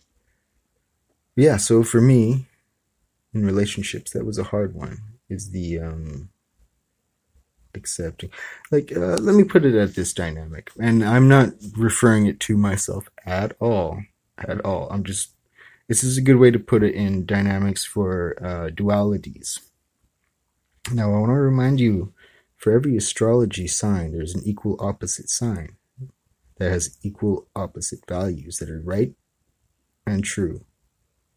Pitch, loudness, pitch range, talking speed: 100 Hz, -21 LUFS, 90-115 Hz, 145 wpm